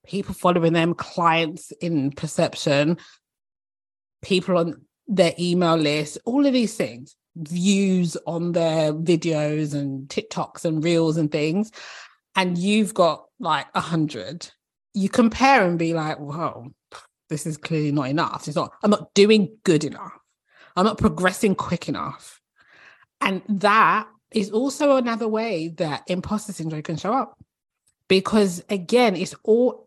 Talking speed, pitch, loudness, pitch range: 140 wpm, 175 Hz, -22 LUFS, 160-200 Hz